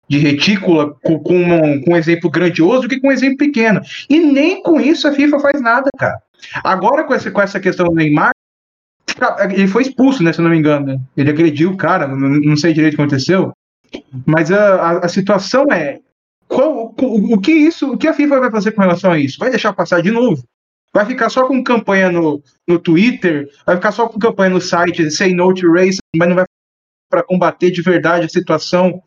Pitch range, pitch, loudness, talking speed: 165-235 Hz, 180 Hz, -13 LUFS, 220 wpm